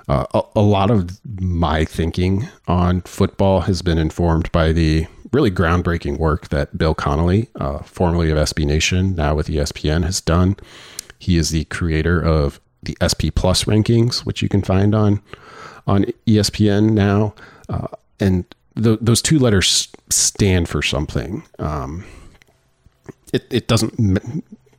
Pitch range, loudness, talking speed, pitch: 80-105 Hz, -18 LUFS, 150 wpm, 90 Hz